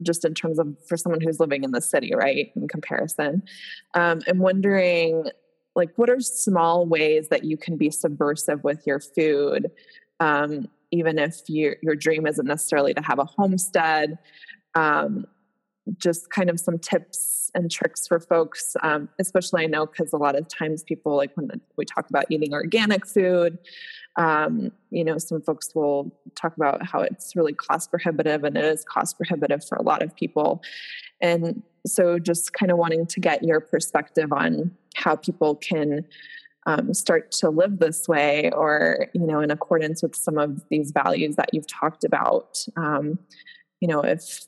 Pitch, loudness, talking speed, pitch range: 165 Hz, -23 LUFS, 175 wpm, 155-185 Hz